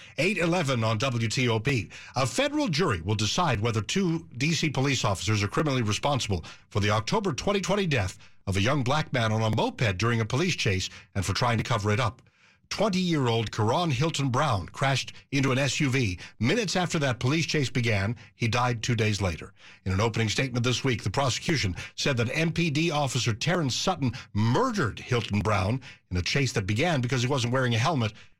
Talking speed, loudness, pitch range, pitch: 190 wpm, -27 LUFS, 110-145 Hz, 125 Hz